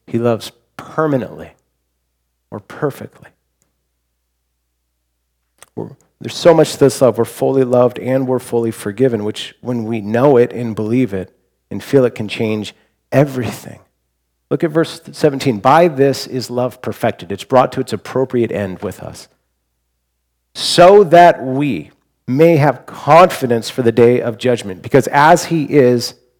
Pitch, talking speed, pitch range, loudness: 120 Hz, 145 wpm, 95-135 Hz, -14 LUFS